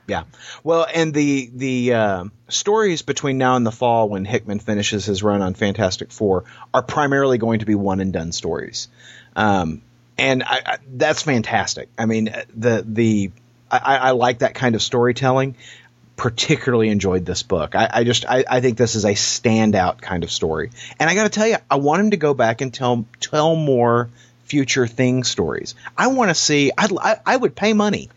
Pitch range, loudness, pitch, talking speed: 110-140 Hz, -19 LUFS, 125 Hz, 195 wpm